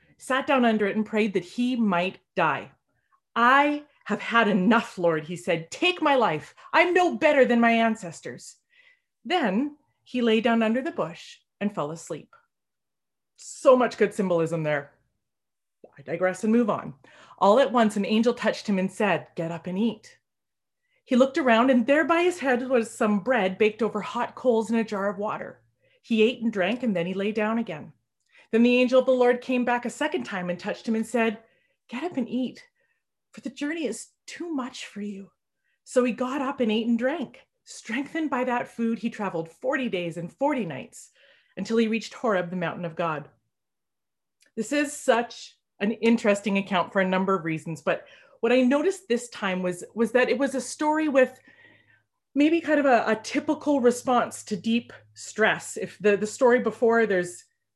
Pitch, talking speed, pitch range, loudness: 230 Hz, 190 wpm, 195-260 Hz, -25 LUFS